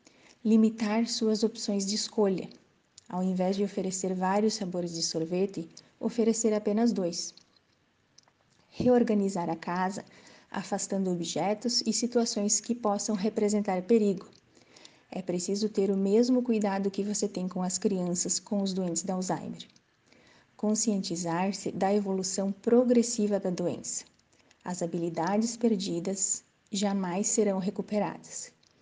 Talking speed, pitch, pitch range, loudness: 115 wpm, 200 Hz, 185-220 Hz, -29 LUFS